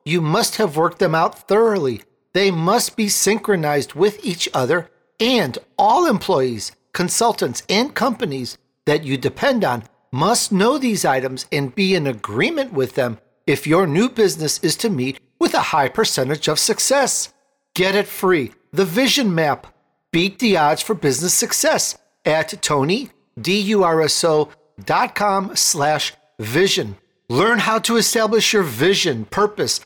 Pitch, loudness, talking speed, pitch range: 190 Hz, -18 LUFS, 135 wpm, 150-215 Hz